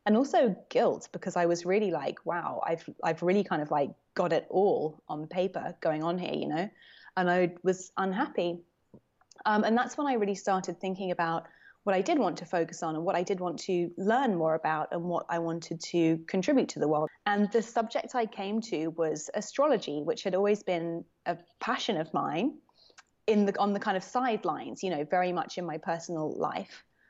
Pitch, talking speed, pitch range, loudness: 180 Hz, 210 wpm, 165-210 Hz, -30 LUFS